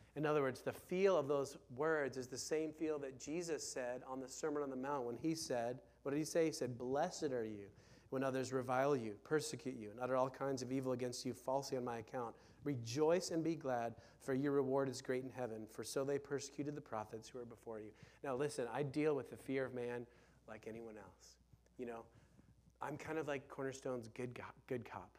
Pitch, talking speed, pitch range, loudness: 130 Hz, 225 wpm, 120-145 Hz, -42 LUFS